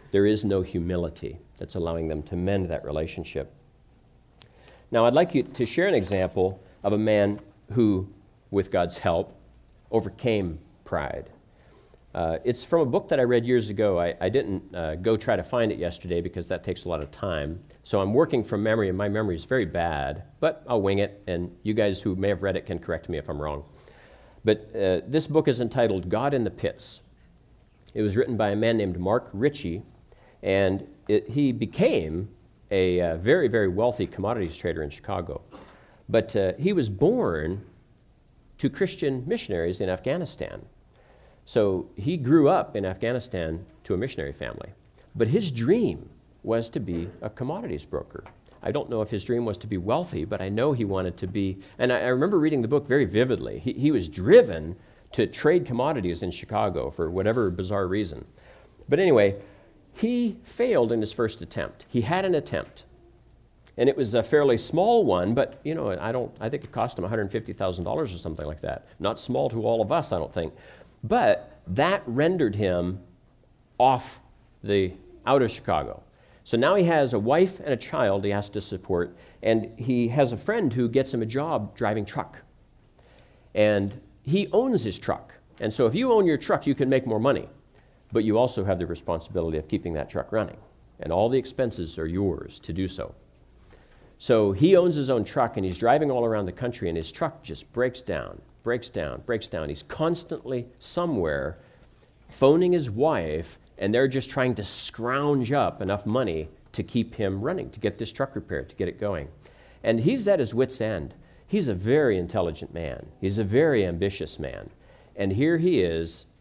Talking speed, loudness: 190 wpm, -26 LUFS